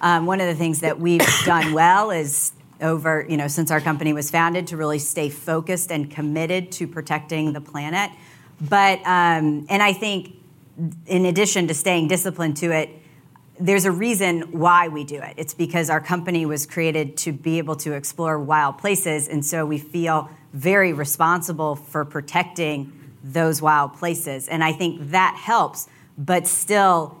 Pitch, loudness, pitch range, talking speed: 160 Hz, -20 LUFS, 150-175 Hz, 170 wpm